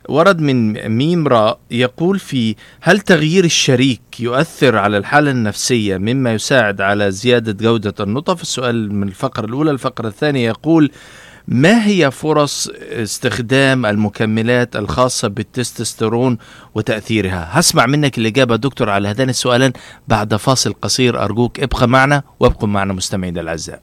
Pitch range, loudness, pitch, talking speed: 110-140 Hz, -15 LUFS, 125 Hz, 130 wpm